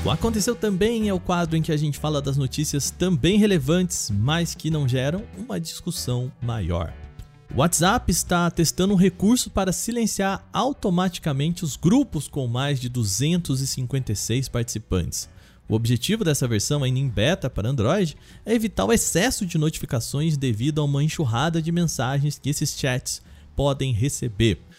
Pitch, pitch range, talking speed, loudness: 150 Hz, 130-180 Hz, 155 wpm, -23 LUFS